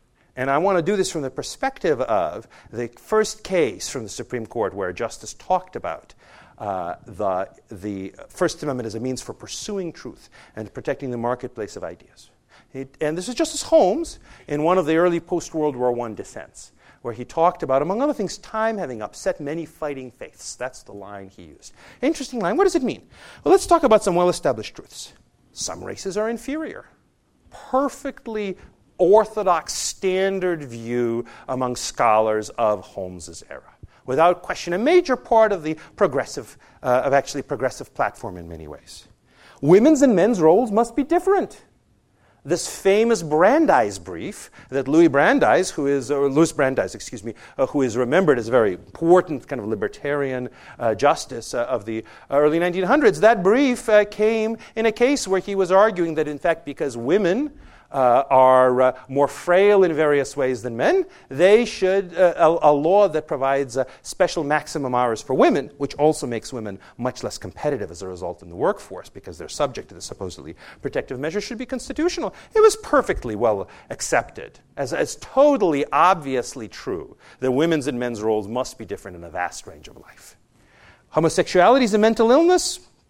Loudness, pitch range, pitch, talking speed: -21 LUFS, 125-215 Hz, 160 Hz, 180 wpm